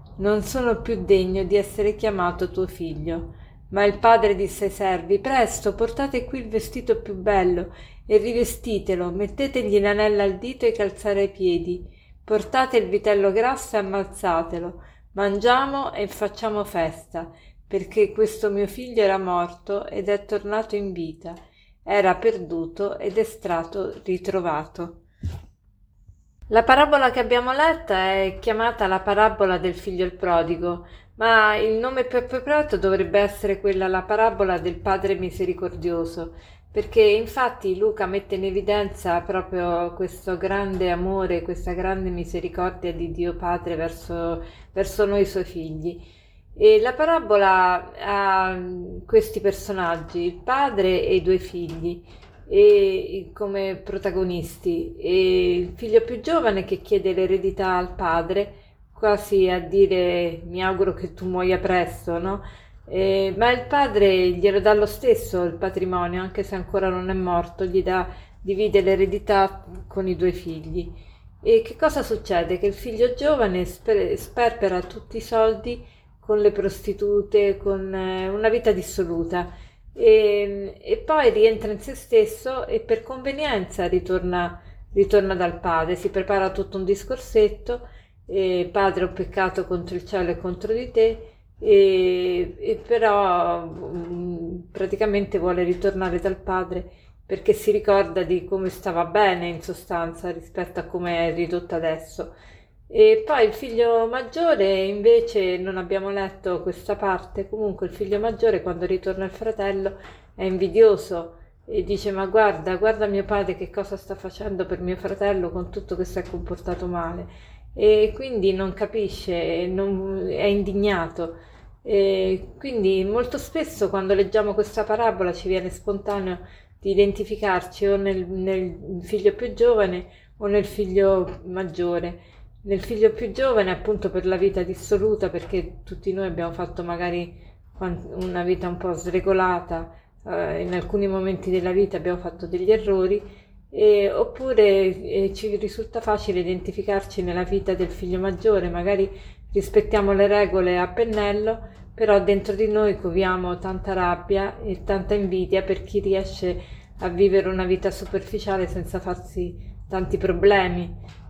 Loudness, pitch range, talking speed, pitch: -22 LUFS, 180-215 Hz, 140 wpm, 195 Hz